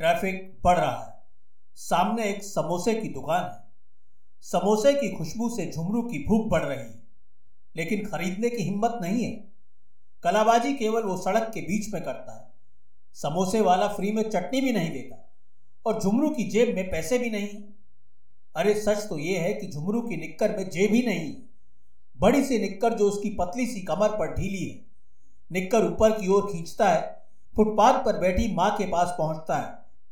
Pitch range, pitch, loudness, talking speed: 170-220 Hz, 200 Hz, -26 LUFS, 175 wpm